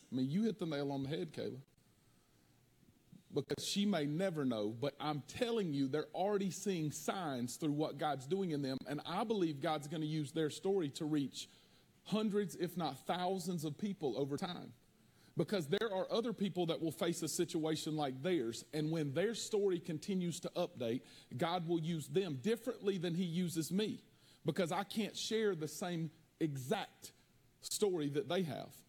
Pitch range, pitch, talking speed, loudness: 145-190 Hz, 165 Hz, 180 wpm, -39 LUFS